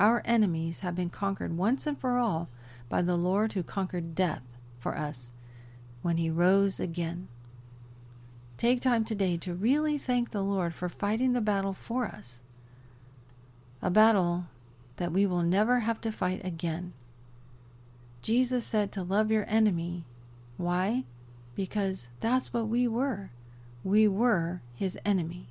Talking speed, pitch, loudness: 145 wpm, 180 Hz, -29 LUFS